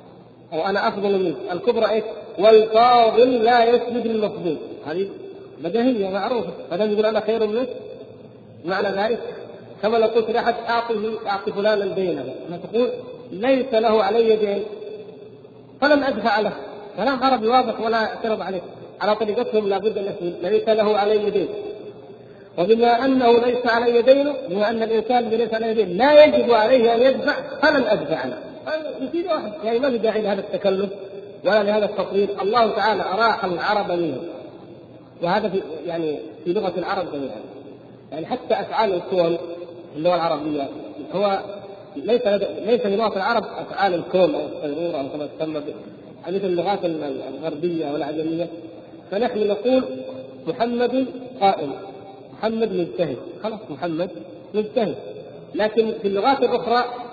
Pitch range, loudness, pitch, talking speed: 180-235 Hz, -21 LUFS, 215 Hz, 135 wpm